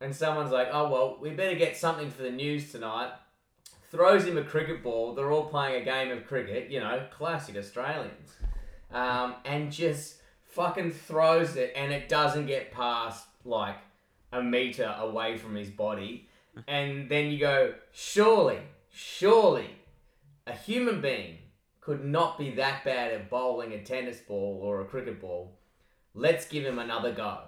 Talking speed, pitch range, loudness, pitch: 165 wpm, 115-155 Hz, -29 LUFS, 135 Hz